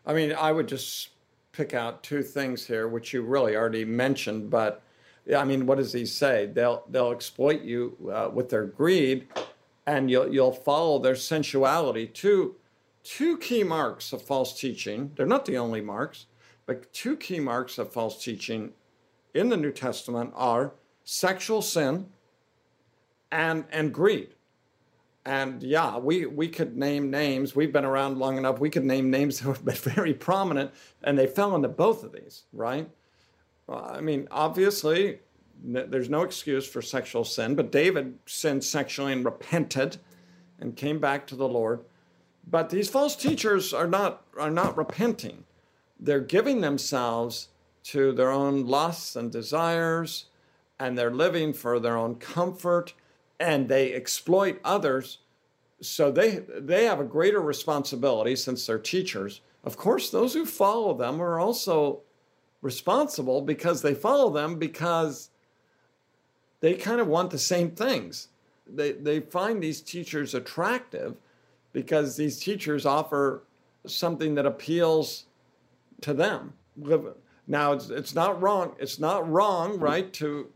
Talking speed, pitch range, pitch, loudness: 150 wpm, 130-165 Hz, 145 Hz, -27 LUFS